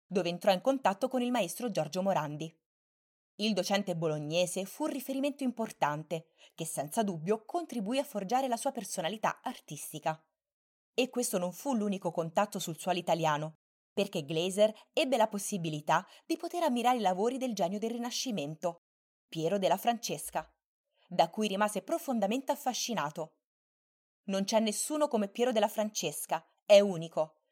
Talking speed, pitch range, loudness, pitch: 145 wpm, 170-245 Hz, -32 LUFS, 205 Hz